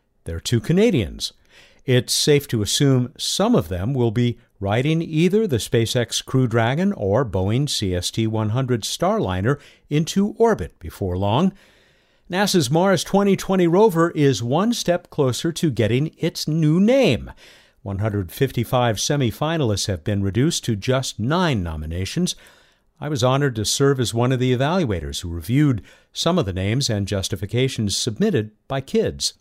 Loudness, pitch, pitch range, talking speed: -20 LUFS, 130 Hz, 105-165 Hz, 145 wpm